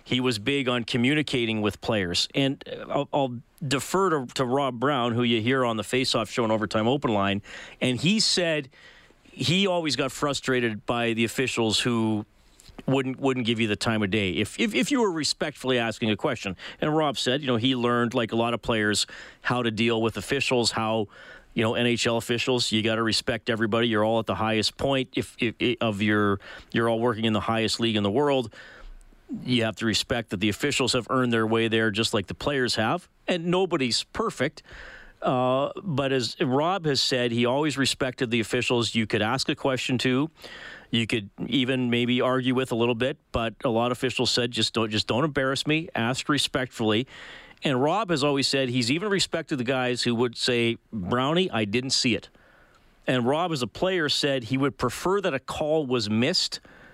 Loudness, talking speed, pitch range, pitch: -25 LUFS, 205 wpm, 115-135 Hz, 125 Hz